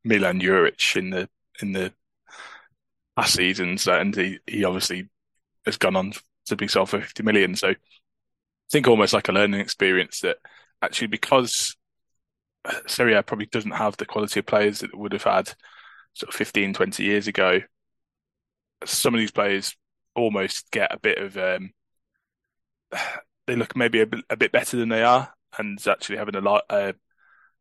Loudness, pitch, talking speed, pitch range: -23 LUFS, 100 Hz, 170 wpm, 95-110 Hz